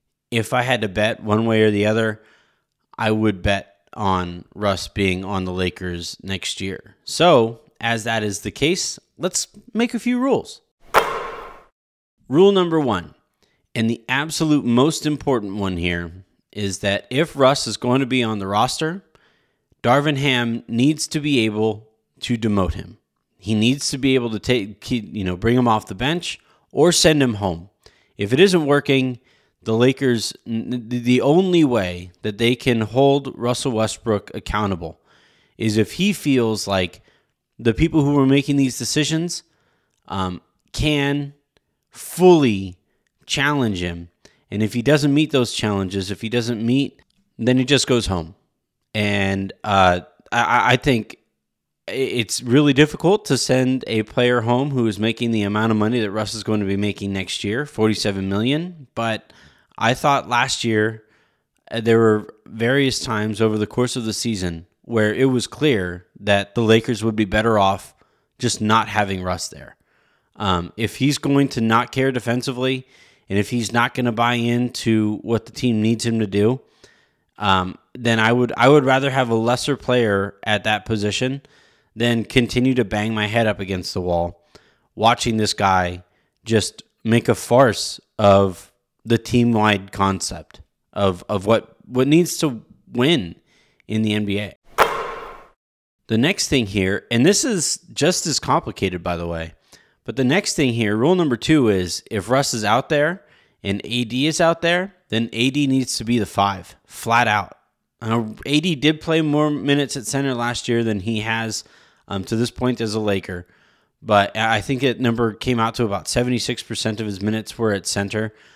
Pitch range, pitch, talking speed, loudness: 105-130 Hz, 115 Hz, 170 wpm, -20 LUFS